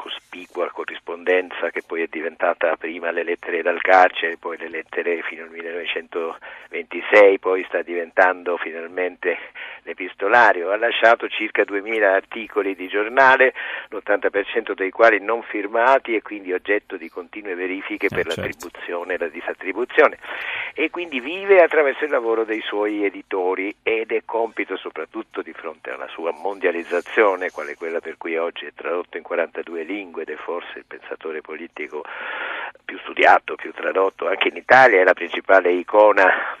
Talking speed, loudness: 150 wpm, -20 LUFS